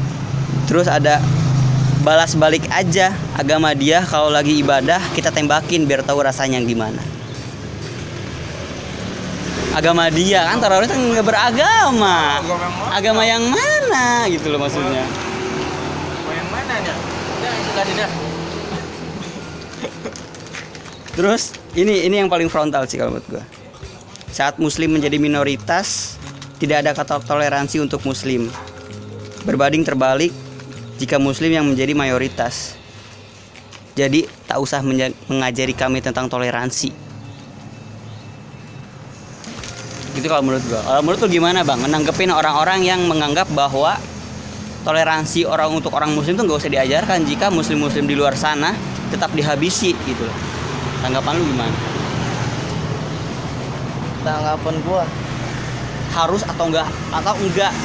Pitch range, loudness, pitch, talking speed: 130-160 Hz, -18 LUFS, 145 Hz, 115 wpm